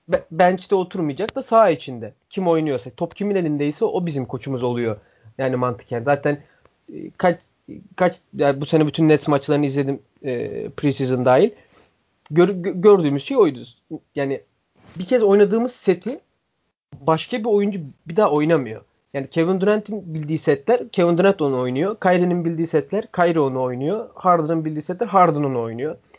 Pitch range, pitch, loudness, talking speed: 140-190 Hz, 160 Hz, -20 LUFS, 155 wpm